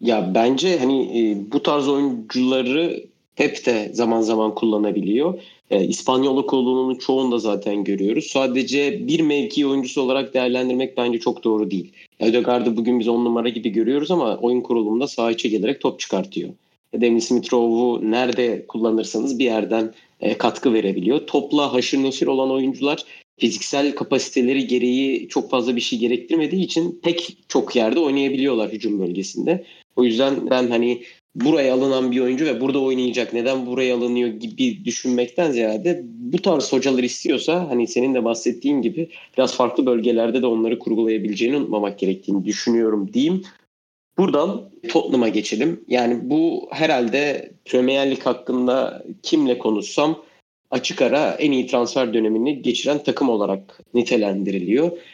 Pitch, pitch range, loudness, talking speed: 125 Hz, 115-135 Hz, -20 LUFS, 140 wpm